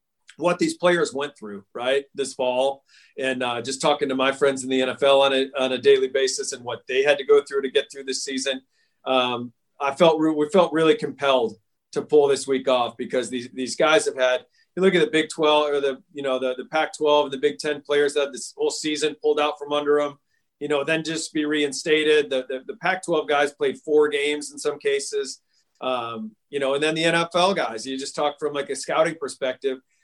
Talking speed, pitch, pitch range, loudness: 230 wpm, 145 Hz, 130-155 Hz, -22 LUFS